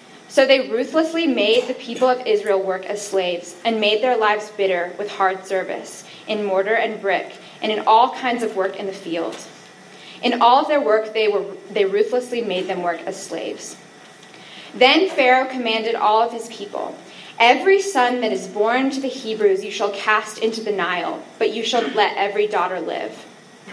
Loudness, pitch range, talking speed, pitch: -19 LUFS, 200-250 Hz, 185 wpm, 220 Hz